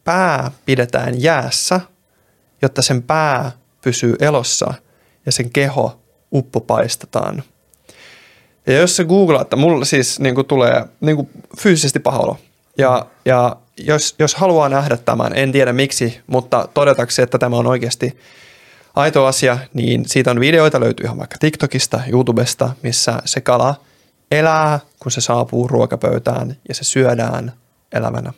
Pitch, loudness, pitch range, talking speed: 135 Hz, -15 LUFS, 125-150 Hz, 135 wpm